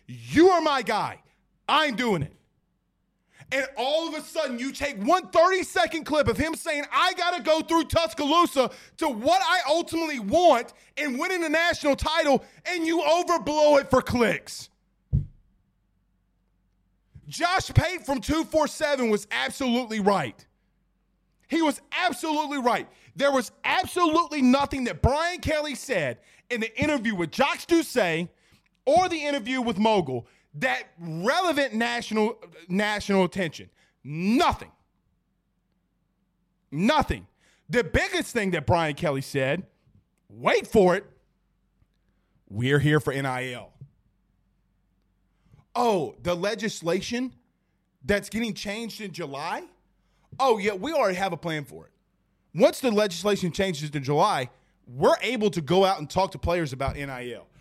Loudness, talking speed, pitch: -25 LUFS, 135 wpm, 240 Hz